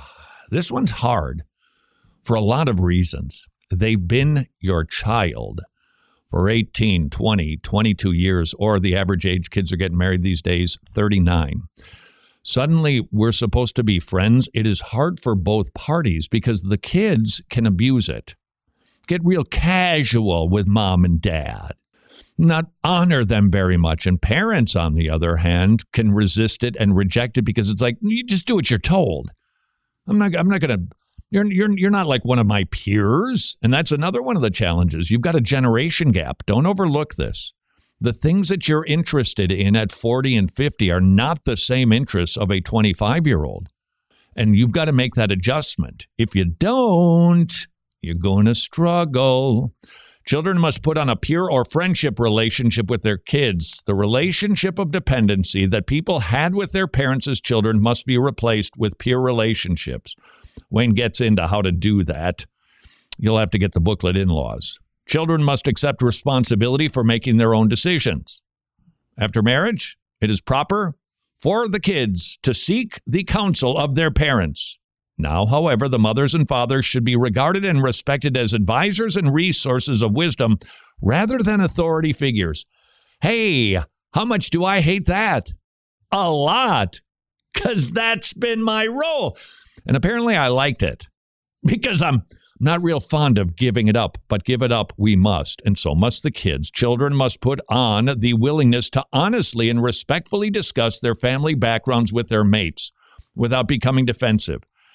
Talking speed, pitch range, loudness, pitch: 165 wpm, 100-150 Hz, -19 LUFS, 120 Hz